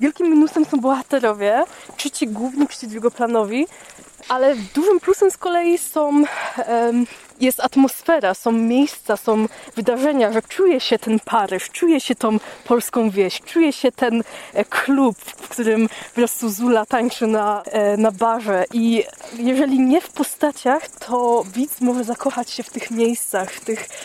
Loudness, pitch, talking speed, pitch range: -19 LUFS, 245 Hz, 150 wpm, 225-290 Hz